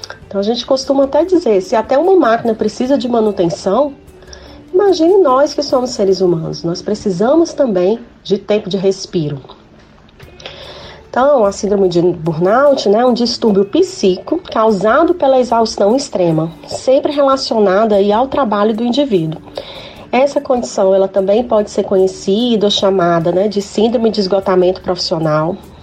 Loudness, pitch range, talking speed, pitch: -13 LUFS, 195-270 Hz, 140 wpm, 215 Hz